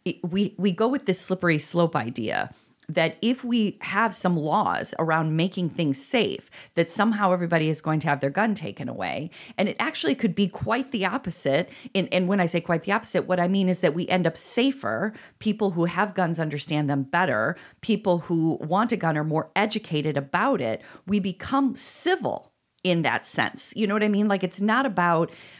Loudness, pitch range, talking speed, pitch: -25 LUFS, 165-210 Hz, 200 wpm, 180 Hz